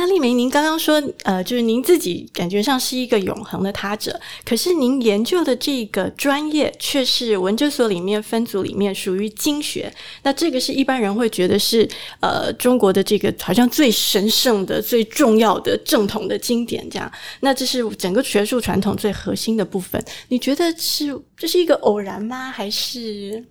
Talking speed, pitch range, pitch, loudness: 285 characters per minute, 205-270 Hz, 235 Hz, -19 LUFS